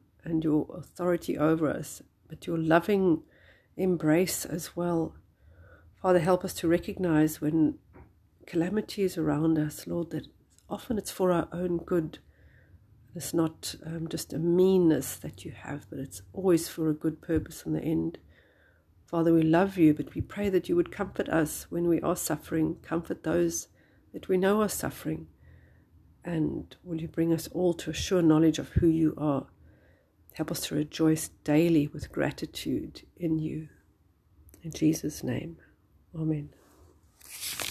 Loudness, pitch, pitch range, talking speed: -29 LUFS, 160 Hz, 110-170 Hz, 155 wpm